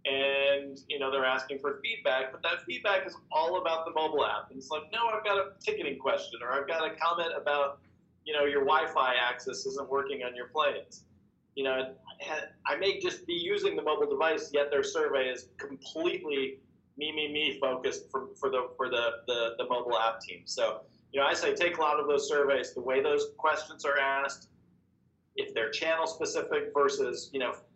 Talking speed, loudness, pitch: 205 wpm, -31 LUFS, 170 Hz